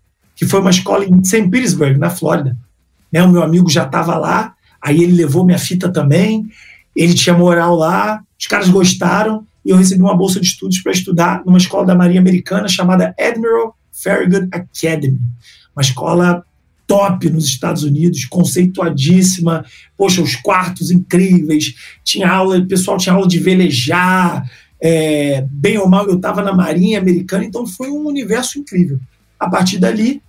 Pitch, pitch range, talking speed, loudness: 180 Hz, 165-195 Hz, 165 wpm, -13 LUFS